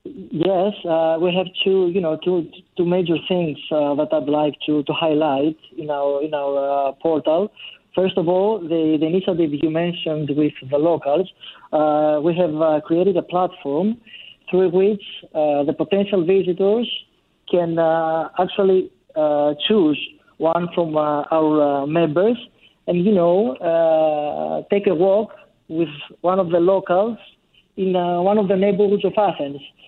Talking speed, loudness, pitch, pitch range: 160 wpm, -19 LUFS, 175 Hz, 155-190 Hz